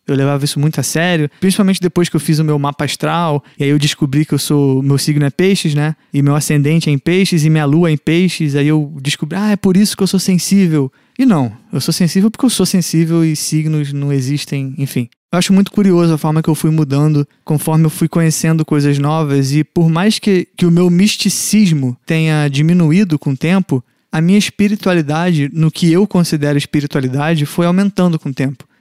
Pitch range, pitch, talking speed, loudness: 145-180 Hz, 160 Hz, 220 wpm, -13 LUFS